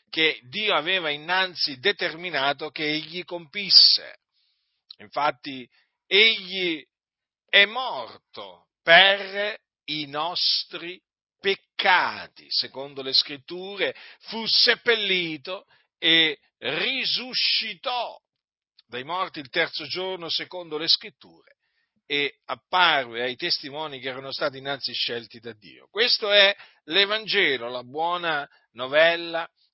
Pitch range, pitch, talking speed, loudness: 145-195 Hz, 165 Hz, 95 wpm, -22 LUFS